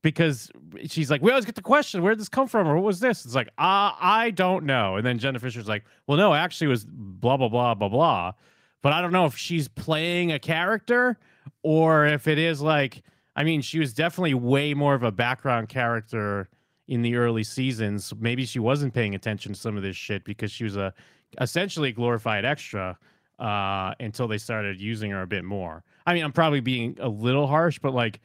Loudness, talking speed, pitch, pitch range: -24 LUFS, 220 wpm, 130 Hz, 110-160 Hz